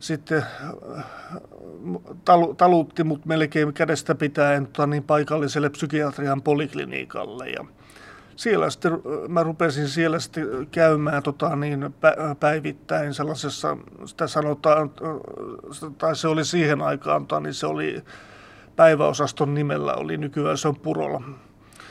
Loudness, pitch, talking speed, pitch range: -23 LUFS, 150 Hz, 105 wpm, 145-160 Hz